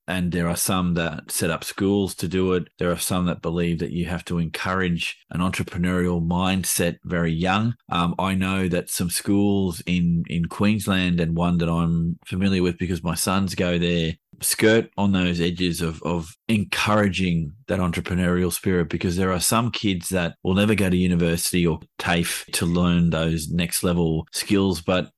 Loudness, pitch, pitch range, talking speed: -23 LUFS, 90 Hz, 85-95 Hz, 180 wpm